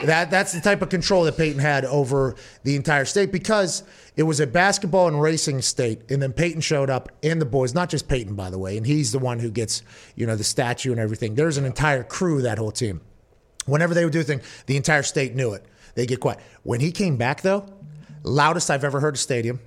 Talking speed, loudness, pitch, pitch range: 245 wpm, -22 LUFS, 145 Hz, 125-160 Hz